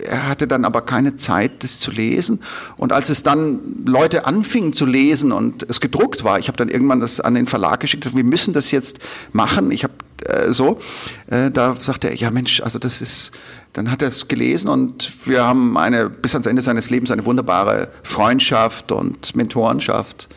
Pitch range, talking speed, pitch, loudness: 120-140 Hz, 190 wpm, 130 Hz, -16 LUFS